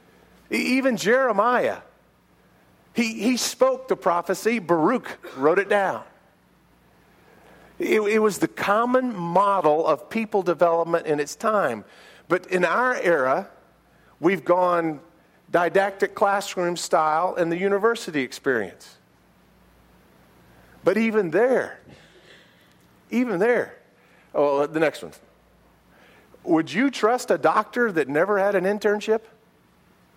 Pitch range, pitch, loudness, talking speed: 170-230 Hz, 200 Hz, -22 LUFS, 110 wpm